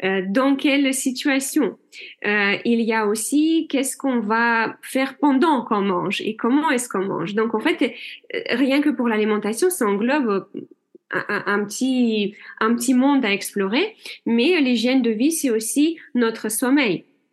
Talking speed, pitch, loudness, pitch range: 155 wpm, 250 Hz, -20 LUFS, 220-290 Hz